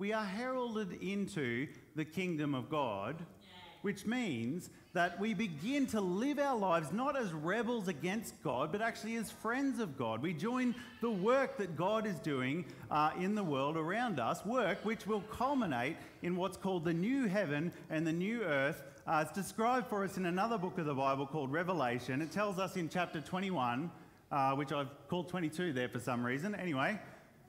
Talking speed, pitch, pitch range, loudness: 185 wpm, 180 Hz, 155-215 Hz, -37 LUFS